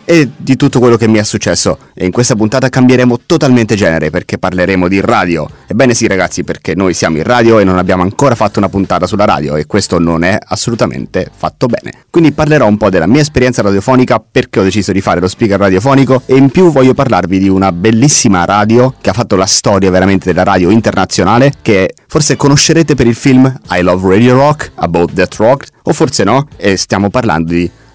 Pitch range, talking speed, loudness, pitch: 95-130 Hz, 210 wpm, -9 LUFS, 110 Hz